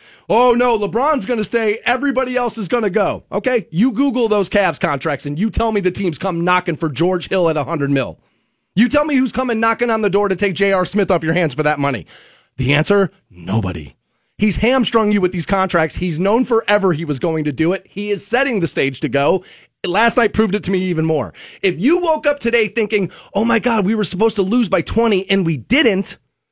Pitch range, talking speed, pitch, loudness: 170-230 Hz, 230 wpm, 200 Hz, -17 LUFS